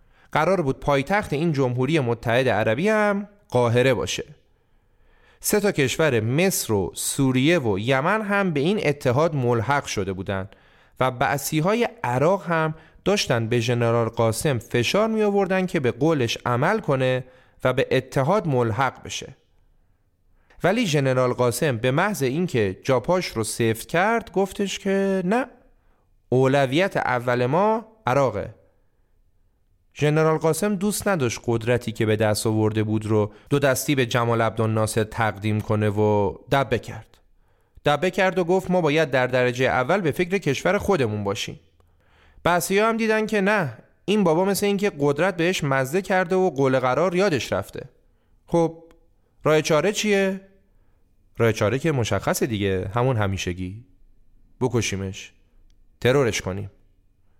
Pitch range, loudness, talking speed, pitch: 110-180 Hz, -22 LUFS, 135 wpm, 130 Hz